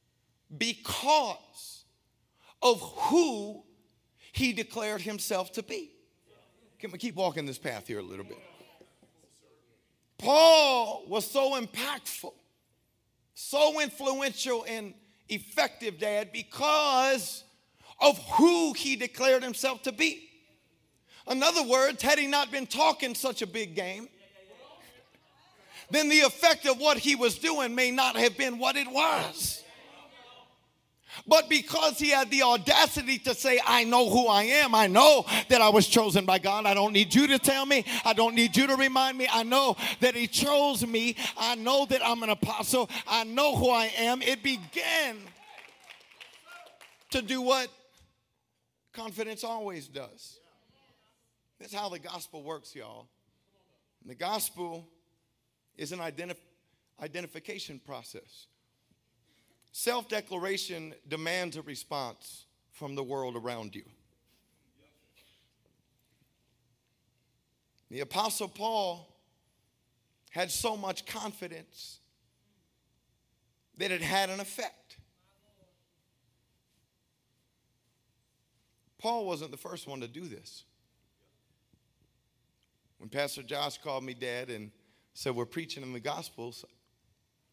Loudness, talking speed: -26 LUFS, 125 wpm